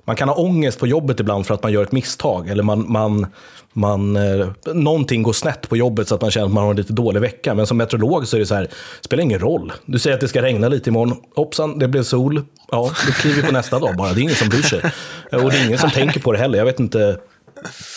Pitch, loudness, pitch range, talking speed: 120 Hz, -18 LUFS, 105-135 Hz, 280 wpm